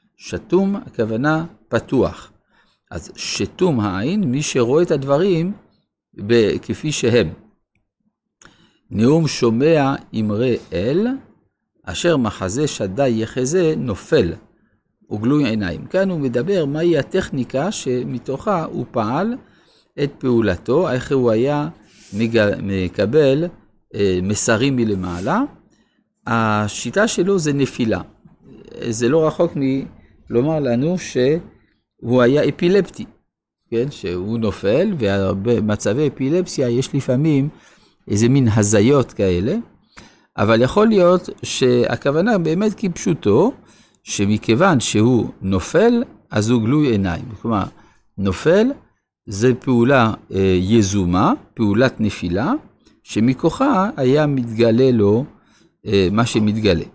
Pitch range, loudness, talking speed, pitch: 110-155 Hz, -18 LUFS, 95 wpm, 125 Hz